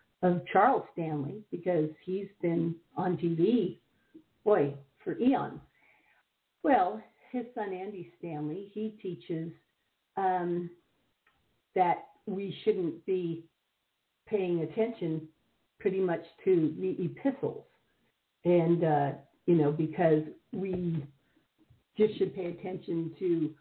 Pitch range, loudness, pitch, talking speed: 165-200 Hz, -31 LUFS, 175 Hz, 105 wpm